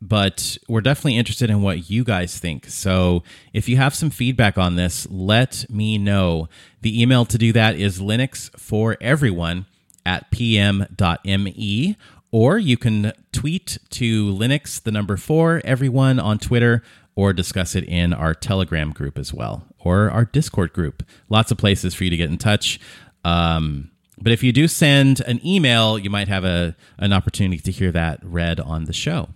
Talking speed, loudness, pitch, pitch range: 175 wpm, -19 LUFS, 105 Hz, 90-120 Hz